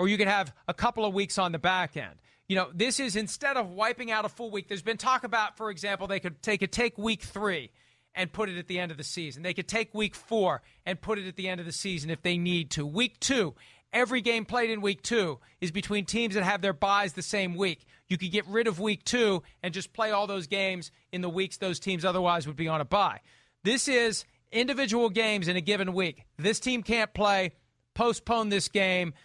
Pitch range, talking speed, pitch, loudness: 180-220 Hz, 245 wpm, 200 Hz, -29 LUFS